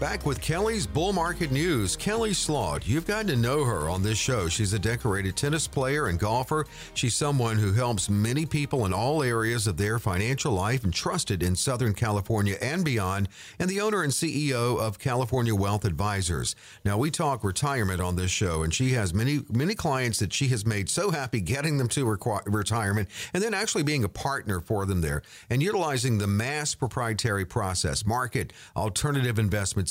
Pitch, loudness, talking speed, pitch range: 120 Hz, -27 LUFS, 190 wpm, 105-145 Hz